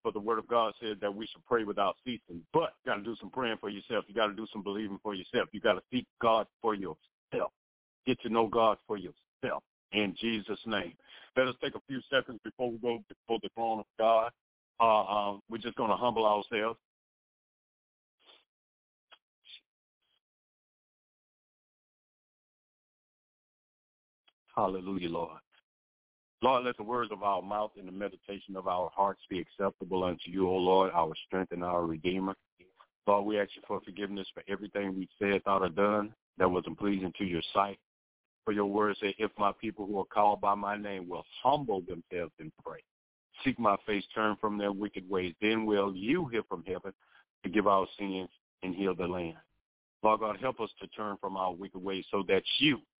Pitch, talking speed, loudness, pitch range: 100 Hz, 185 wpm, -33 LUFS, 95-110 Hz